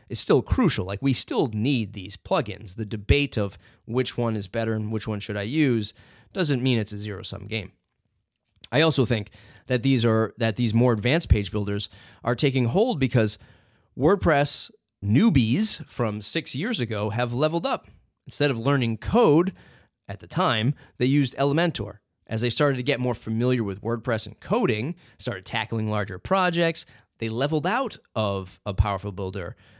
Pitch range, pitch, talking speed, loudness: 105-135 Hz, 115 Hz, 175 wpm, -24 LUFS